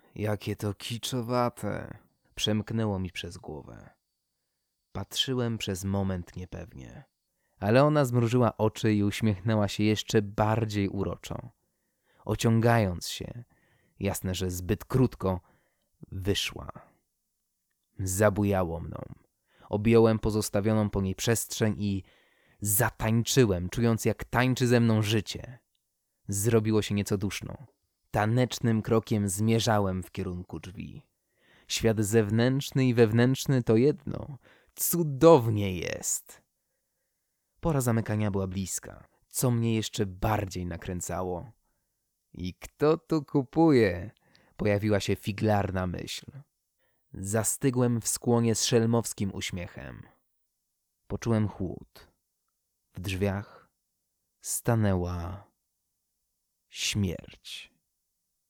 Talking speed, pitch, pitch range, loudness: 90 wpm, 105 Hz, 95-115 Hz, -28 LUFS